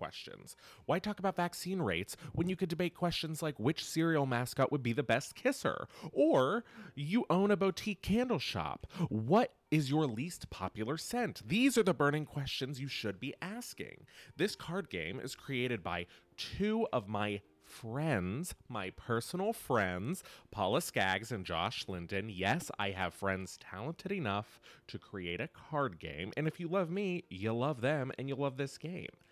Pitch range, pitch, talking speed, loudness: 110-175 Hz, 140 Hz, 170 wpm, -36 LUFS